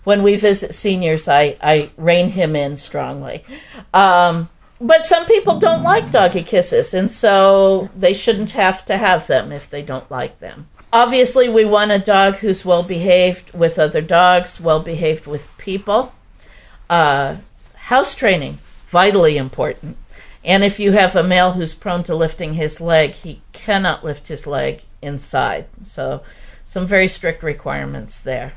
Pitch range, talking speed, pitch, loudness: 155-200 Hz, 160 wpm, 180 Hz, -15 LUFS